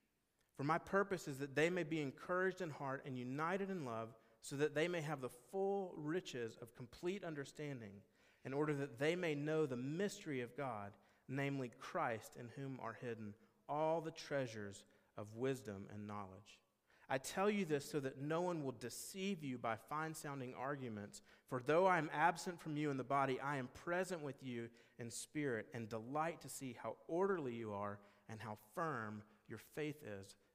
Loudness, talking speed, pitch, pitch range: -43 LUFS, 185 wpm, 135 Hz, 115-155 Hz